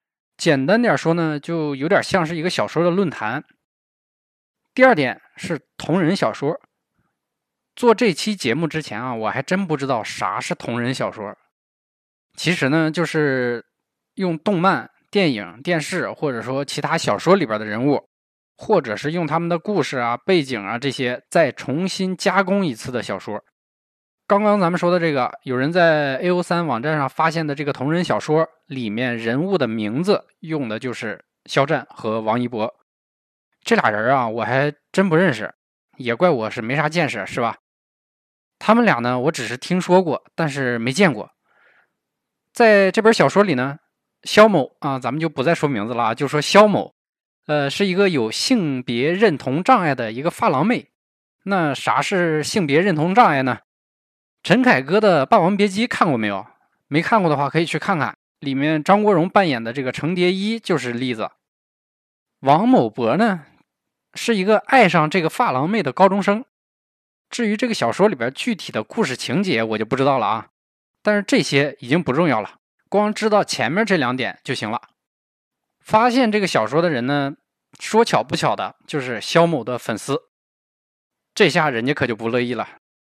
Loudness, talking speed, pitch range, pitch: -19 LUFS, 255 characters per minute, 130-190 Hz, 160 Hz